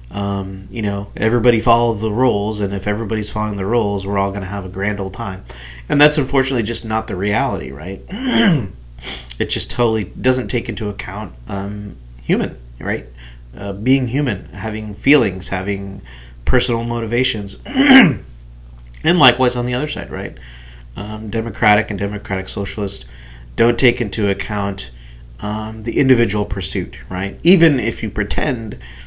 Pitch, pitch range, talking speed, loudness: 105 Hz, 95-115 Hz, 150 wpm, -18 LUFS